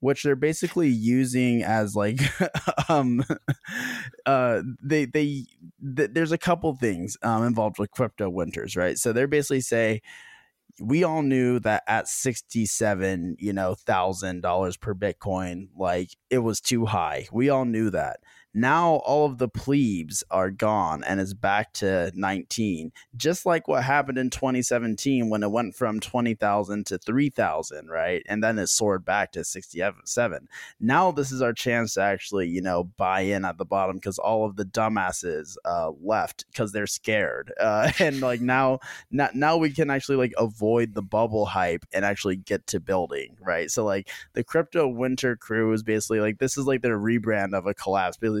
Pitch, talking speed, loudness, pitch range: 115 Hz, 175 wpm, -25 LUFS, 100-135 Hz